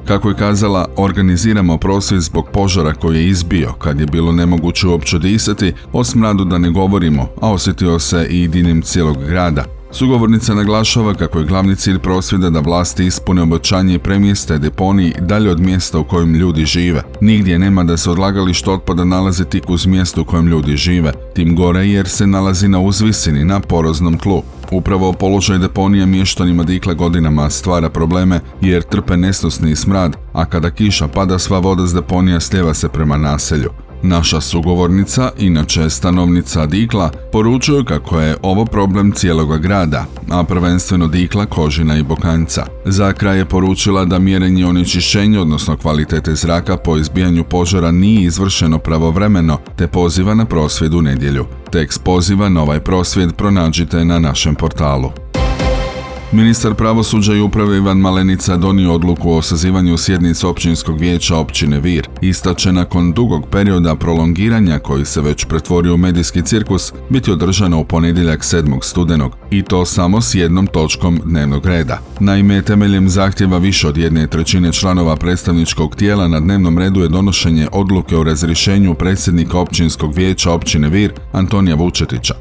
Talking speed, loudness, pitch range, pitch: 155 wpm, -13 LUFS, 80-95 Hz, 90 Hz